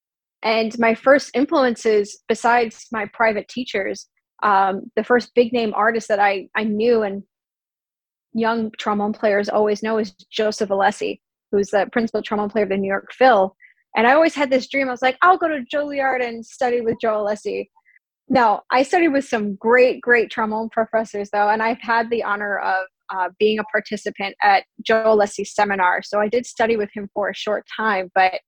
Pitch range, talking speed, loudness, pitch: 205-240 Hz, 190 wpm, -19 LUFS, 220 Hz